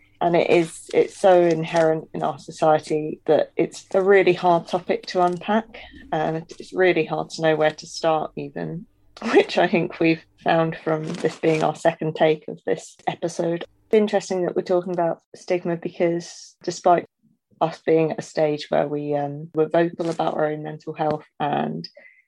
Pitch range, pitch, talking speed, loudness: 155-180 Hz, 165 Hz, 180 wpm, -22 LUFS